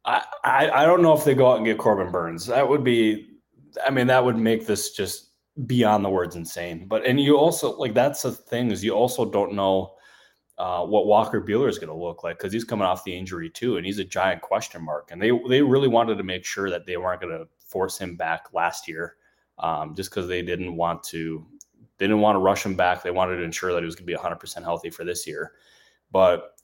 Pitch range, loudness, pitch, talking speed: 90-125 Hz, -23 LUFS, 100 Hz, 245 wpm